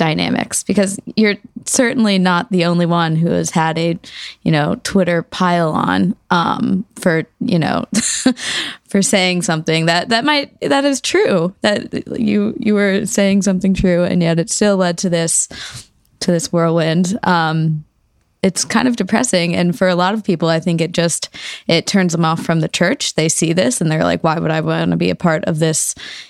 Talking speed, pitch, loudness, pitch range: 195 wpm, 180 Hz, -16 LUFS, 165-205 Hz